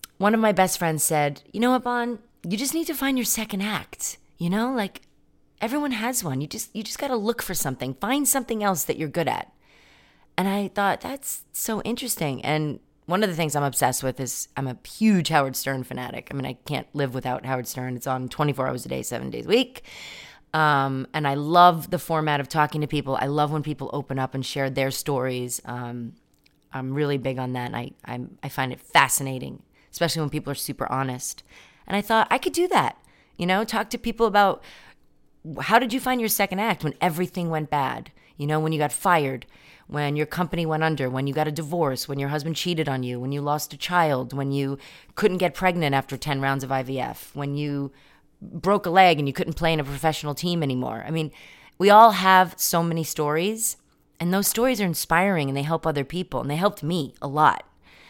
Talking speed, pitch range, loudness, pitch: 225 wpm, 135-195 Hz, -24 LUFS, 155 Hz